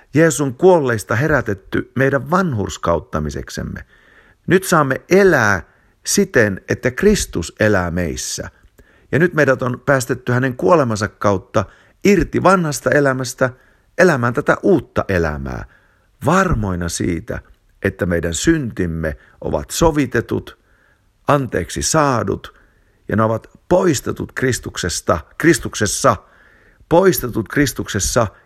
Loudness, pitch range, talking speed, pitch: -17 LUFS, 100-160 Hz, 95 wpm, 125 Hz